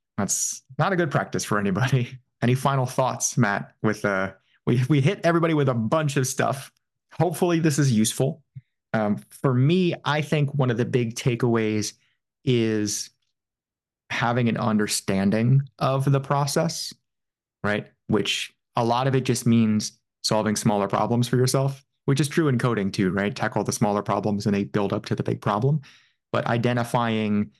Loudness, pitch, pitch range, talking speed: -24 LUFS, 120 Hz, 110-140 Hz, 165 wpm